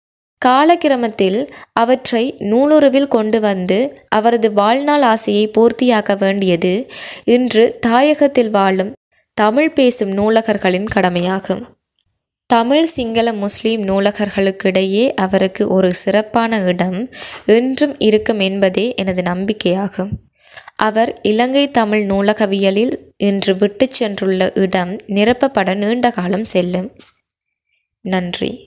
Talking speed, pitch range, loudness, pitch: 90 wpm, 195-240 Hz, -14 LUFS, 215 Hz